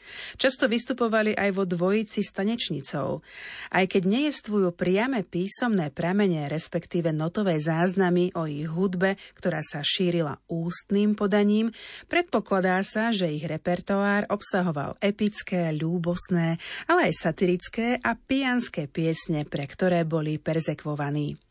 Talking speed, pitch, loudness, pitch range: 115 wpm, 185 Hz, -26 LUFS, 165-210 Hz